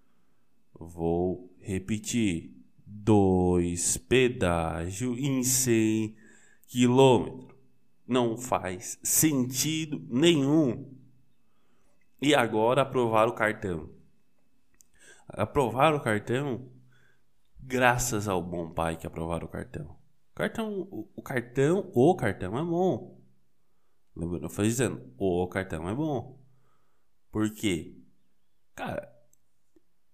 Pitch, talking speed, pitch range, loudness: 110 Hz, 90 wpm, 90-130 Hz, -27 LUFS